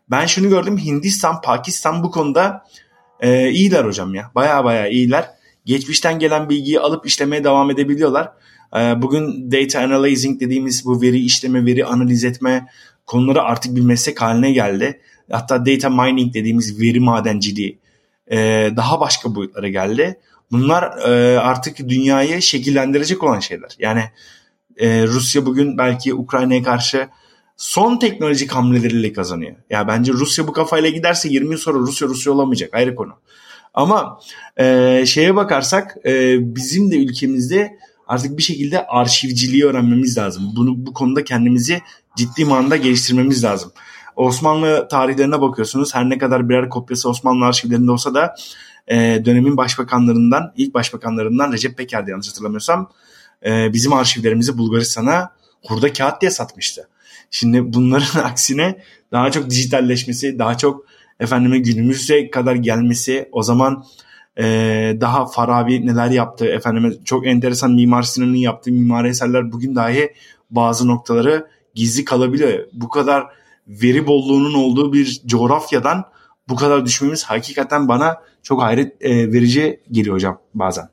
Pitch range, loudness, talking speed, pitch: 120-140 Hz, -16 LUFS, 135 wpm, 130 Hz